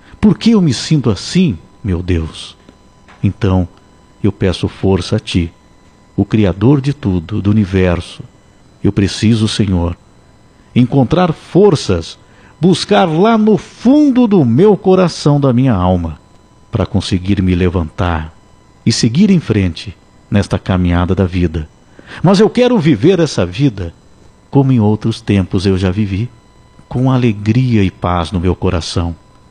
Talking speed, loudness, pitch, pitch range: 135 wpm, -13 LUFS, 100 Hz, 90-135 Hz